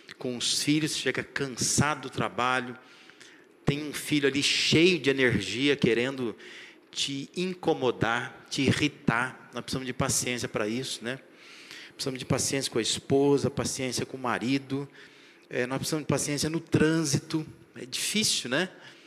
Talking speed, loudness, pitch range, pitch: 145 wpm, -27 LUFS, 125-155 Hz, 135 Hz